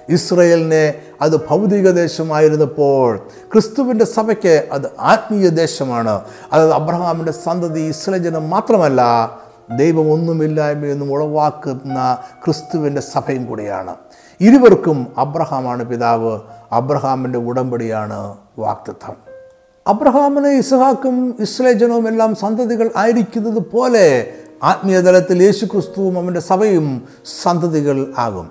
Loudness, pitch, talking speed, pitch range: -15 LUFS, 160 Hz, 80 wpm, 135-205 Hz